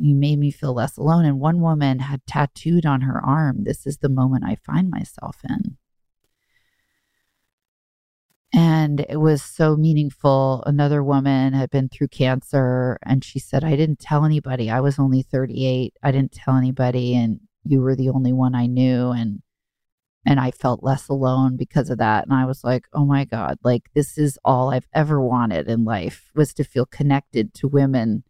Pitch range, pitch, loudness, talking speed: 125-145 Hz, 135 Hz, -20 LUFS, 185 wpm